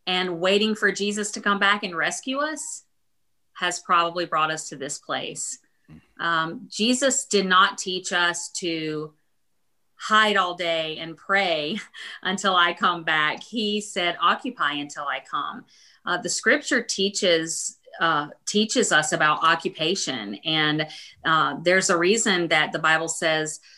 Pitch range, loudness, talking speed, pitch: 160-205 Hz, -23 LUFS, 145 wpm, 180 Hz